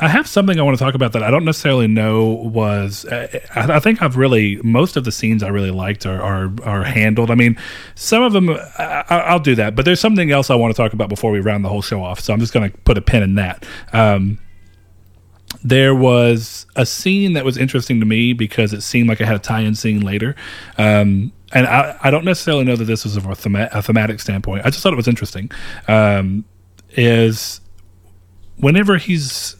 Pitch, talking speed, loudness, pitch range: 110 Hz, 225 wpm, -15 LUFS, 100-130 Hz